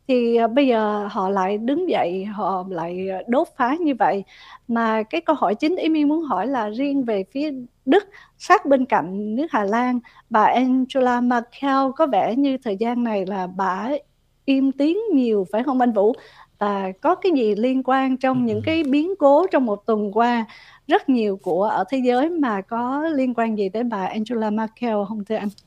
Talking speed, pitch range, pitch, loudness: 195 wpm, 215-280 Hz, 245 Hz, -21 LUFS